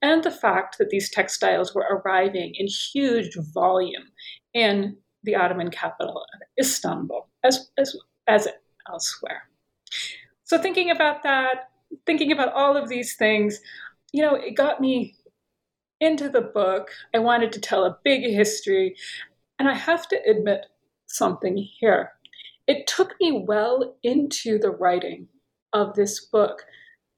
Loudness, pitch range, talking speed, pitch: -23 LUFS, 210-300 Hz, 135 wpm, 250 Hz